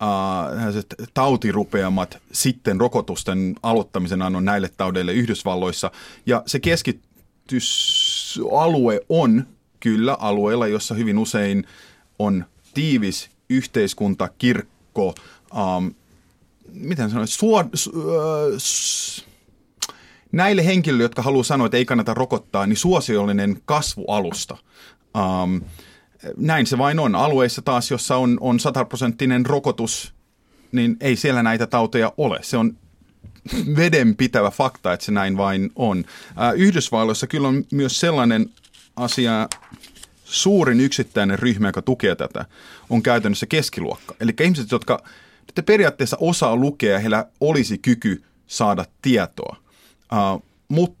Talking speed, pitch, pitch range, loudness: 115 wpm, 120 Hz, 100-140 Hz, -20 LUFS